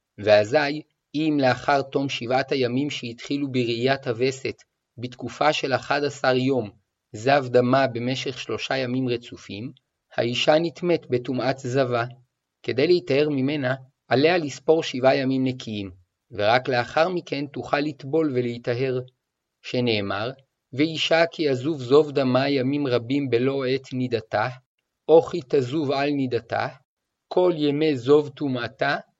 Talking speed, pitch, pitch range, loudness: 120 wpm, 130 Hz, 125-145 Hz, -23 LUFS